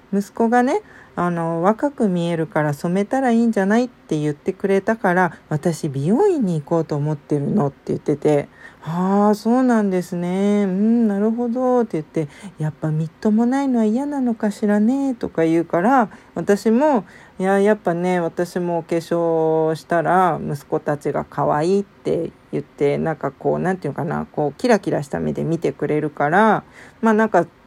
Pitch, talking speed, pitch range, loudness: 185 Hz, 345 characters per minute, 160-220 Hz, -20 LUFS